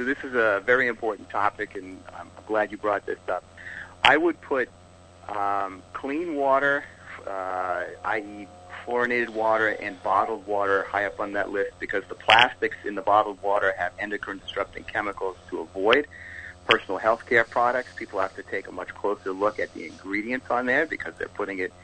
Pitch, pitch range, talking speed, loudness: 100 Hz, 90-110 Hz, 180 wpm, -25 LUFS